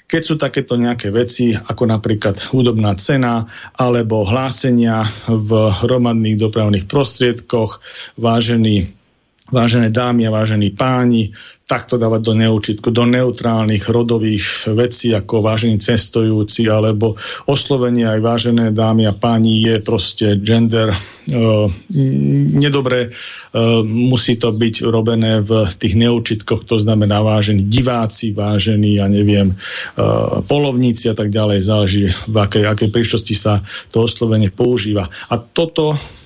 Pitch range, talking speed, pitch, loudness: 105-120 Hz, 125 wpm, 115 Hz, -15 LUFS